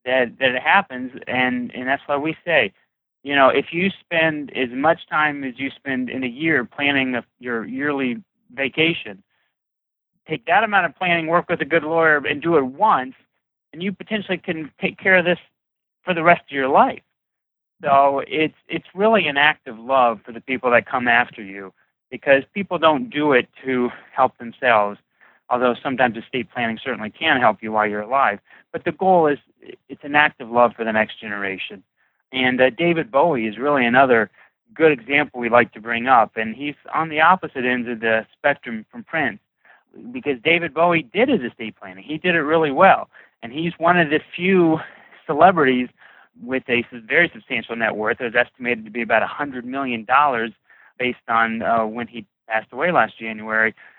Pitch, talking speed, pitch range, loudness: 140 Hz, 190 wpm, 120-165 Hz, -19 LUFS